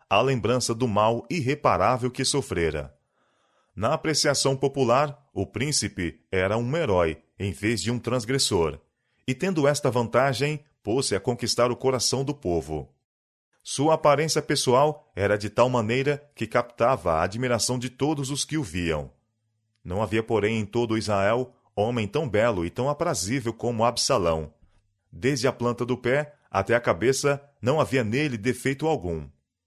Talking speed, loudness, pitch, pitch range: 150 wpm, -25 LUFS, 120 Hz, 105-140 Hz